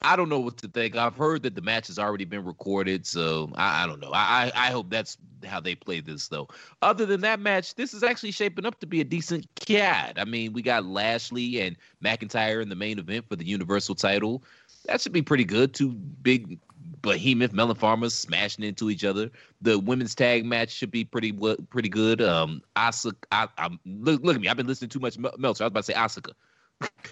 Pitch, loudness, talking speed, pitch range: 120 Hz, -26 LUFS, 225 wpm, 105-145 Hz